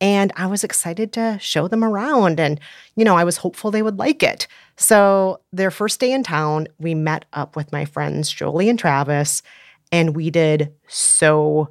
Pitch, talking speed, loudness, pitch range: 170 Hz, 190 wpm, -18 LUFS, 155-210 Hz